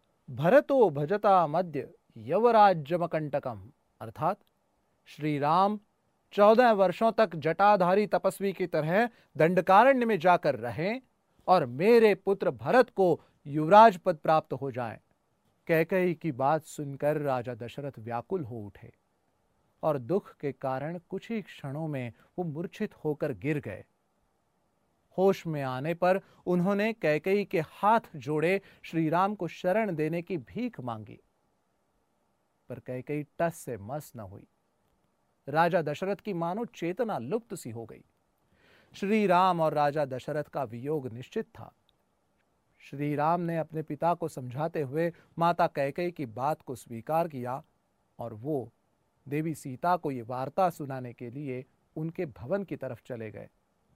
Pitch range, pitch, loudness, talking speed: 140-190 Hz, 160 Hz, -28 LUFS, 135 wpm